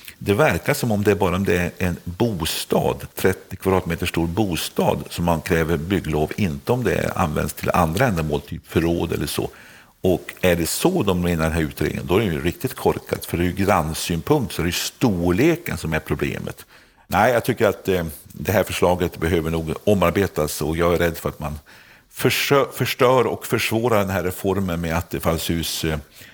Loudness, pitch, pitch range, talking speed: -21 LUFS, 85 Hz, 80-95 Hz, 205 wpm